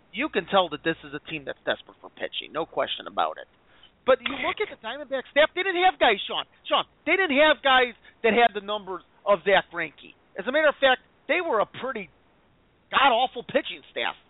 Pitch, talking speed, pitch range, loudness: 255 Hz, 225 wpm, 190-300 Hz, -24 LUFS